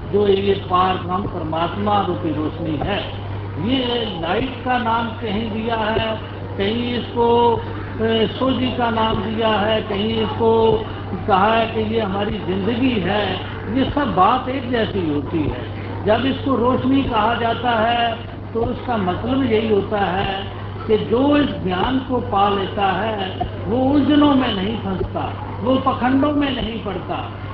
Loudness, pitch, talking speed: -19 LUFS, 220 Hz, 150 wpm